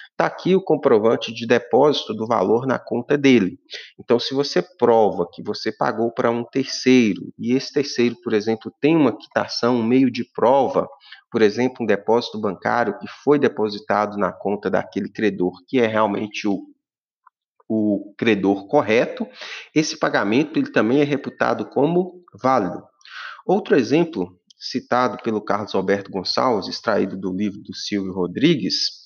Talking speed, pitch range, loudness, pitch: 150 wpm, 105-135 Hz, -20 LUFS, 120 Hz